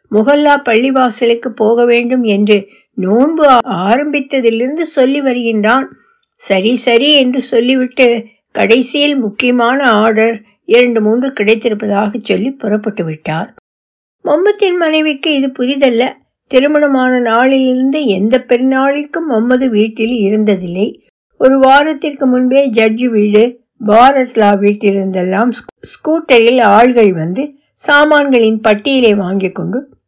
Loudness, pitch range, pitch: -11 LUFS, 215-270 Hz, 245 Hz